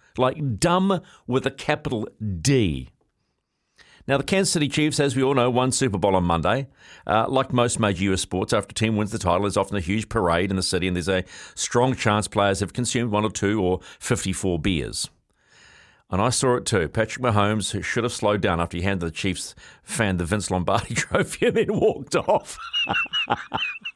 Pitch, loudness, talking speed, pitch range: 105 Hz, -23 LUFS, 200 wpm, 95-125 Hz